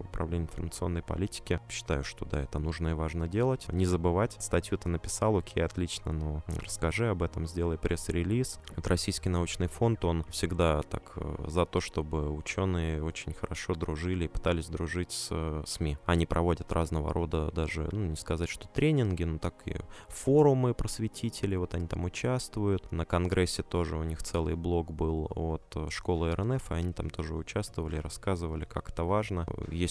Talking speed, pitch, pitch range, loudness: 170 wpm, 85 Hz, 80-100 Hz, -32 LUFS